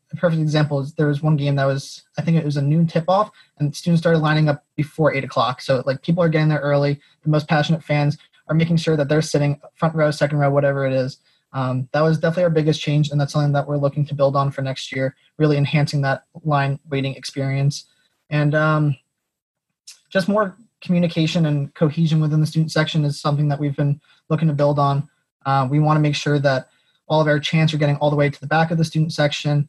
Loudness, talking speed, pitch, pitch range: -20 LUFS, 240 wpm, 150 Hz, 145-160 Hz